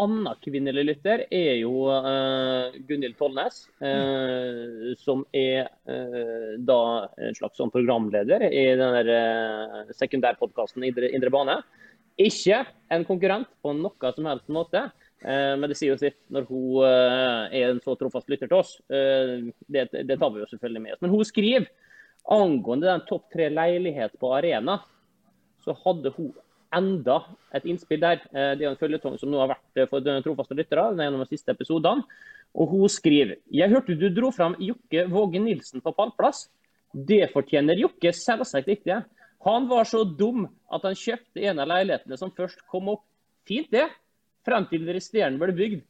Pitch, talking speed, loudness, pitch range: 150 Hz, 175 wpm, -25 LUFS, 130-200 Hz